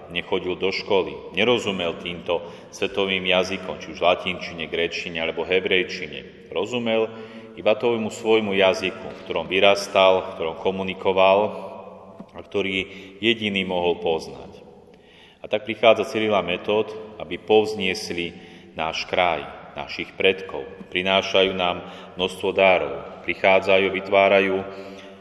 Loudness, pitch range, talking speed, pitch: -22 LUFS, 95-105 Hz, 105 wpm, 95 Hz